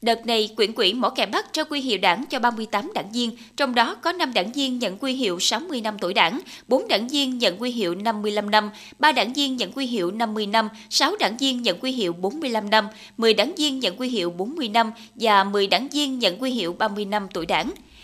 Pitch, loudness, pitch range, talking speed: 235 Hz, -22 LUFS, 215-270 Hz, 235 wpm